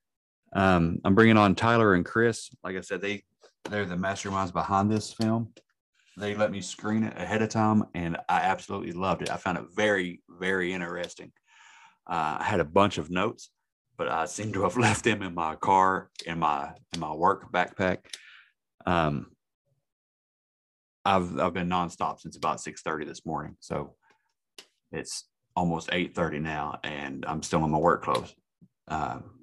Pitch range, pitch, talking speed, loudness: 90-105 Hz, 95 Hz, 170 wpm, -28 LUFS